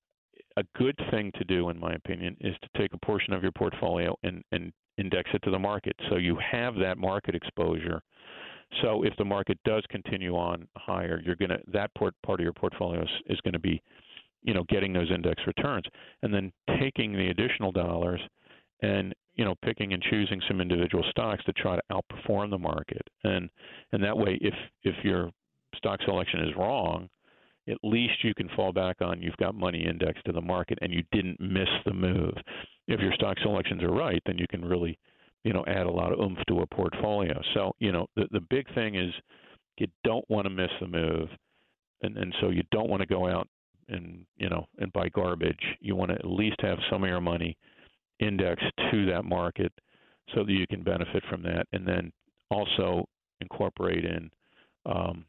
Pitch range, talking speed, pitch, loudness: 85-105 Hz, 200 wpm, 95 Hz, -30 LUFS